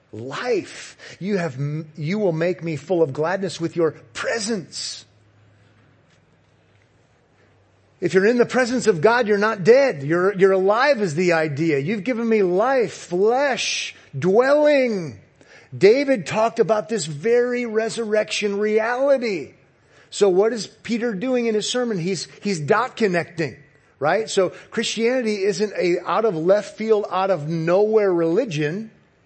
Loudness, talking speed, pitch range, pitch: -20 LUFS, 135 wpm, 160-225 Hz, 195 Hz